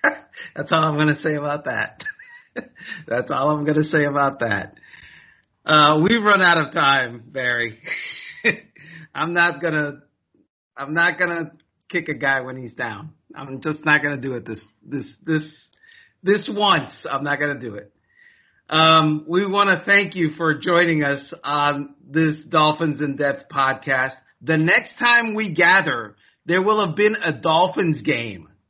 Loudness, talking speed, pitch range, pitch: -19 LUFS, 170 wpm, 140-170 Hz, 155 Hz